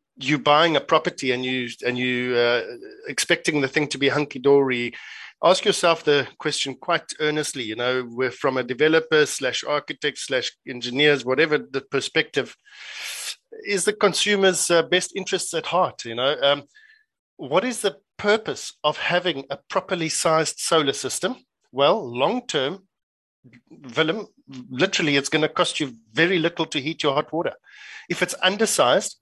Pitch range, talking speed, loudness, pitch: 135-185 Hz, 150 wpm, -22 LUFS, 155 Hz